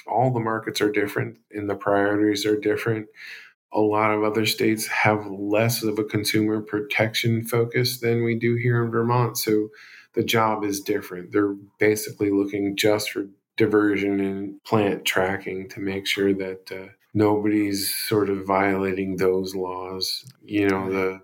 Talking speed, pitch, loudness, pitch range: 160 wpm, 105 Hz, -23 LUFS, 100-110 Hz